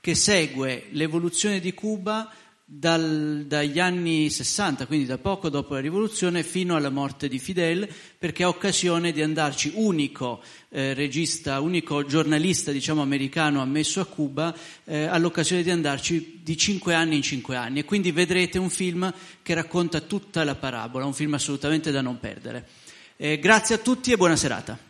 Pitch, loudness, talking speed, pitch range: 160 Hz, -24 LUFS, 165 wpm, 145-180 Hz